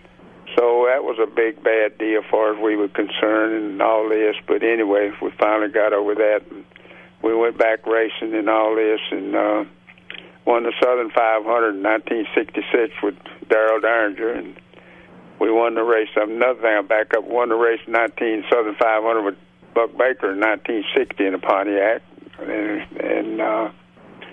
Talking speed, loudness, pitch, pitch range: 170 wpm, -19 LUFS, 110 Hz, 110-115 Hz